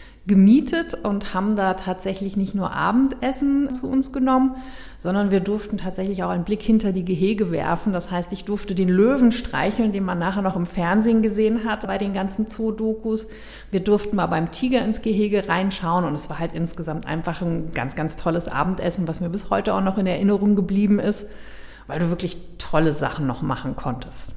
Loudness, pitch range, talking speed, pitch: -22 LUFS, 175-215 Hz, 190 wpm, 195 Hz